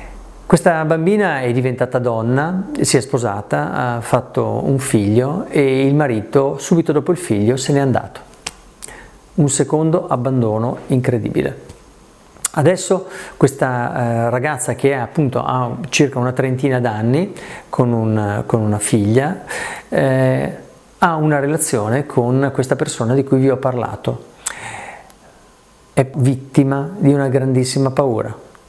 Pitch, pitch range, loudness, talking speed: 135 Hz, 125-150 Hz, -17 LUFS, 120 wpm